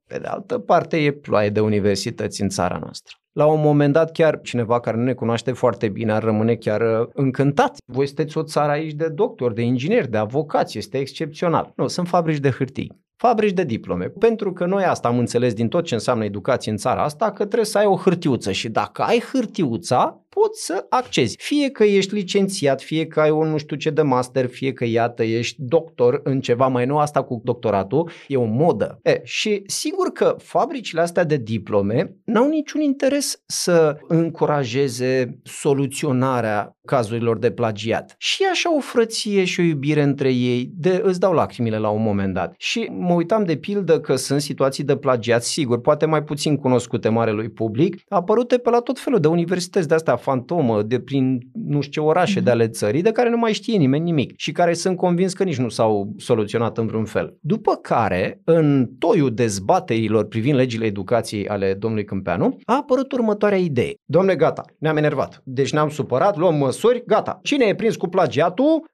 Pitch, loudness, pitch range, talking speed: 150 Hz, -20 LUFS, 120-185 Hz, 195 wpm